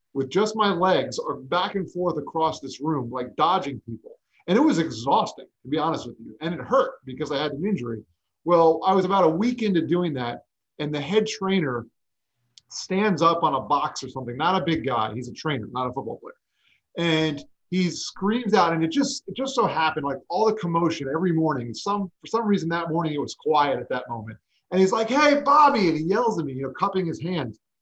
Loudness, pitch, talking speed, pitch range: -24 LUFS, 165 Hz, 230 wpm, 135-195 Hz